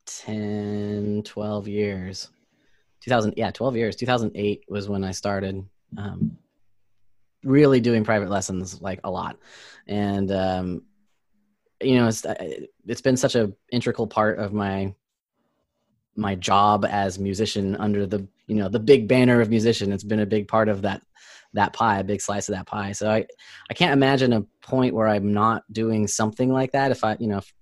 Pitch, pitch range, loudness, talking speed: 105 Hz, 100-115 Hz, -23 LUFS, 175 wpm